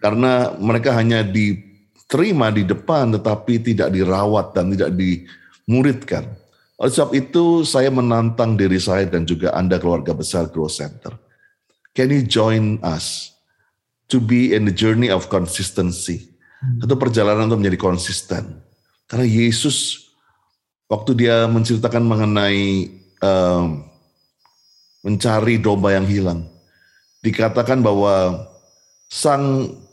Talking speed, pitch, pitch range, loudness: 110 wpm, 105 Hz, 95-120 Hz, -18 LUFS